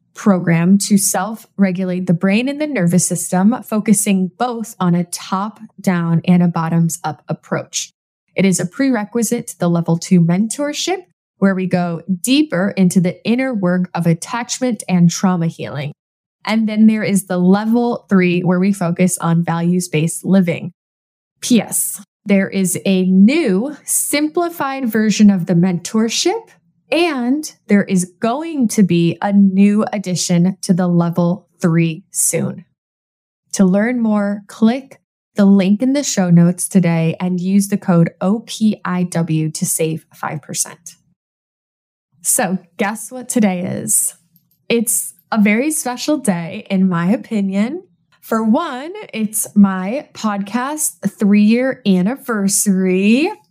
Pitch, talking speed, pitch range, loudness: 195 Hz, 135 wpm, 175-220 Hz, -16 LUFS